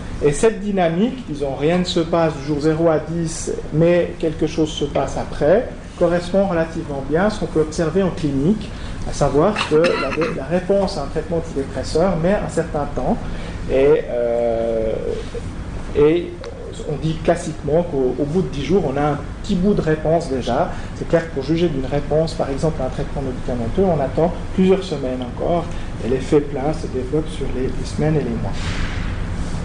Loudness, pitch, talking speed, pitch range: -20 LUFS, 155 Hz, 185 wpm, 135-170 Hz